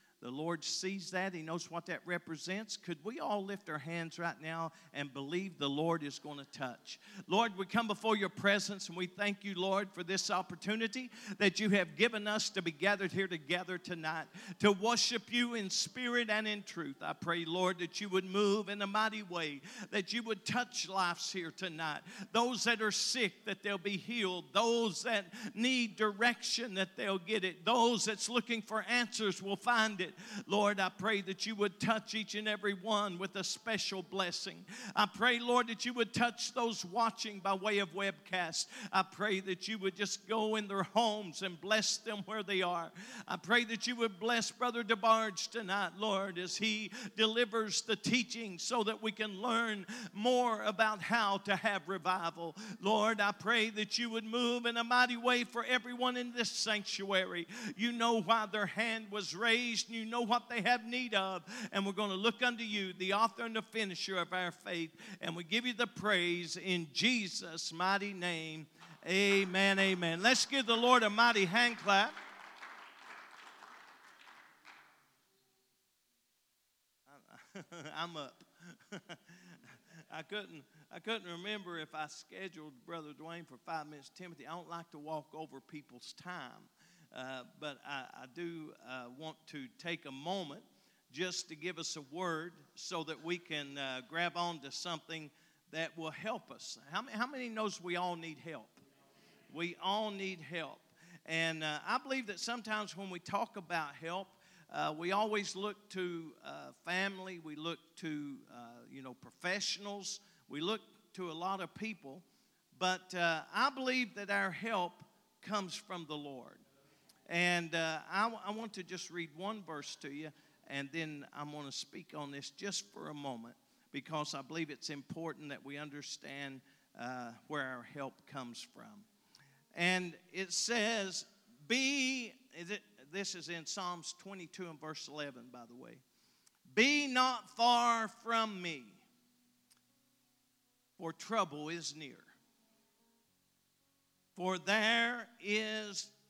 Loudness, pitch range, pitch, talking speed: -36 LUFS, 170-220 Hz, 195 Hz, 170 wpm